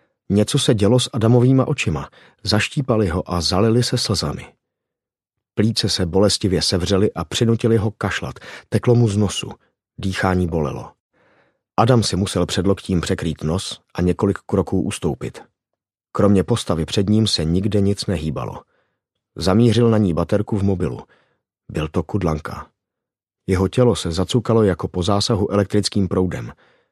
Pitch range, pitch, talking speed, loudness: 90-115 Hz, 100 Hz, 140 wpm, -19 LUFS